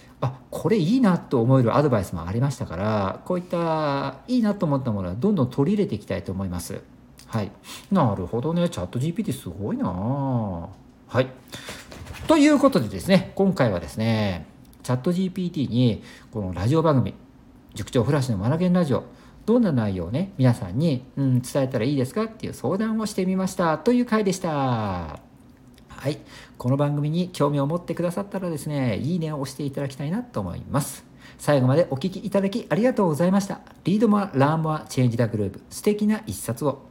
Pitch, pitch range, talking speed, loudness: 140 Hz, 120-185 Hz, 405 characters per minute, -24 LUFS